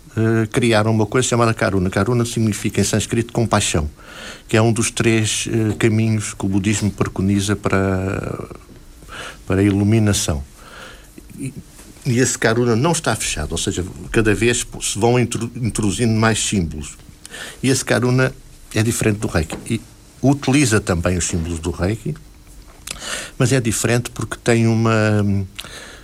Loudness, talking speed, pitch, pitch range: -18 LUFS, 145 wpm, 110 Hz, 100-120 Hz